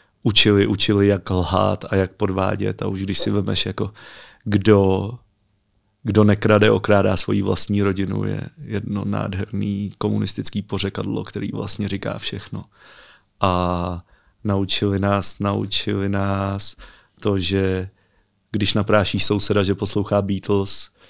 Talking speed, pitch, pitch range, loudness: 120 wpm, 100 Hz, 95-105 Hz, -20 LUFS